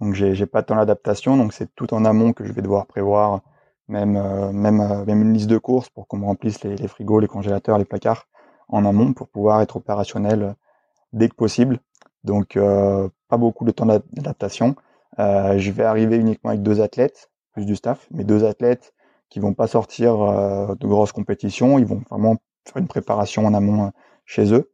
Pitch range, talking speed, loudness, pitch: 100-115 Hz, 205 wpm, -20 LUFS, 105 Hz